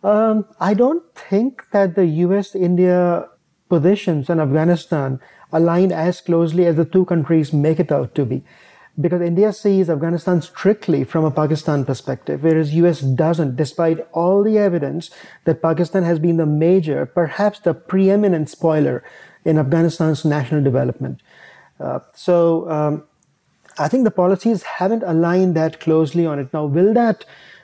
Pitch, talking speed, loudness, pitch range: 170 Hz, 150 wpm, -18 LUFS, 155-190 Hz